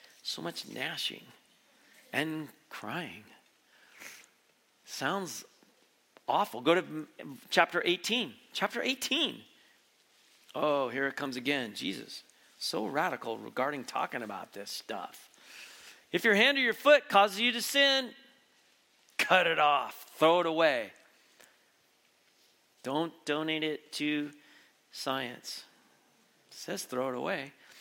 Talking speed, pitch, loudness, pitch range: 110 wpm, 170 Hz, -30 LUFS, 150-240 Hz